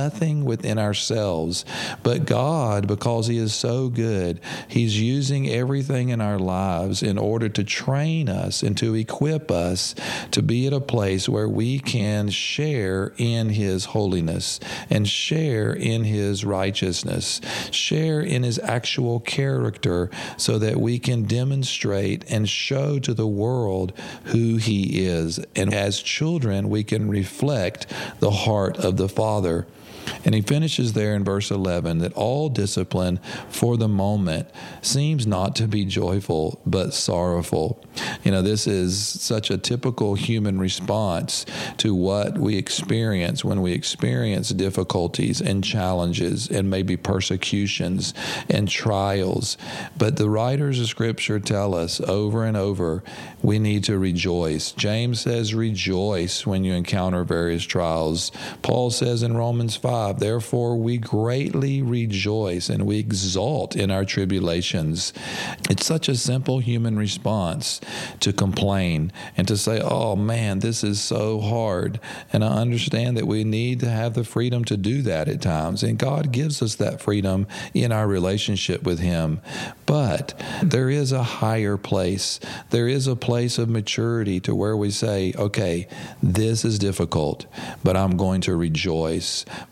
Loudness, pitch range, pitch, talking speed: -23 LUFS, 95-120 Hz, 105 Hz, 145 wpm